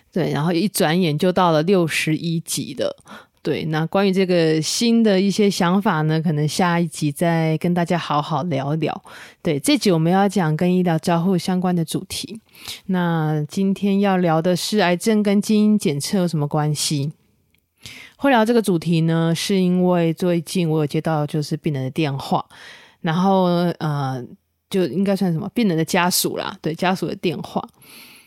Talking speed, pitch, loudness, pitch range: 255 characters per minute, 175 Hz, -20 LUFS, 155-190 Hz